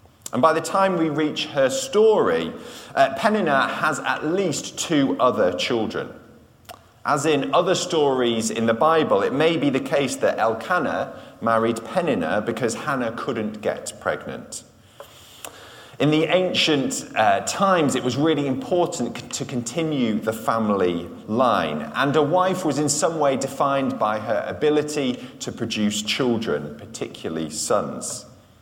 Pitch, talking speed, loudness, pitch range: 145 Hz, 140 wpm, -22 LUFS, 115-170 Hz